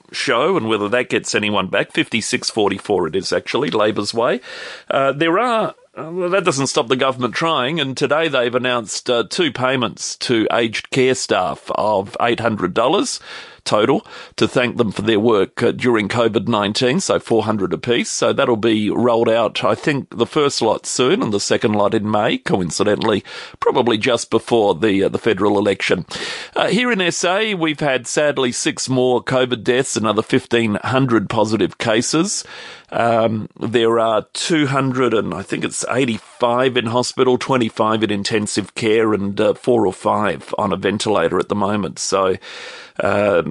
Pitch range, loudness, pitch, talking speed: 115-140 Hz, -18 LUFS, 125 Hz, 180 wpm